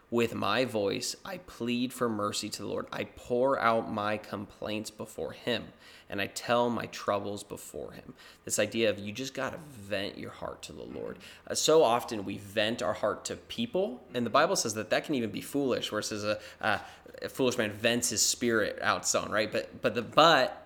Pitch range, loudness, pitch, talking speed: 105-120 Hz, -30 LUFS, 110 Hz, 215 wpm